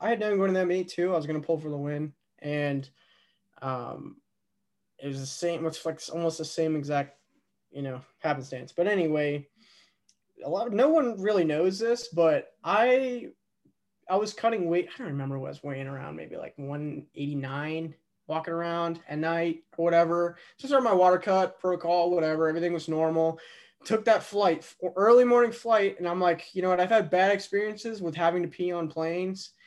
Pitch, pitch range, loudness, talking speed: 170 Hz, 155-190 Hz, -27 LUFS, 195 wpm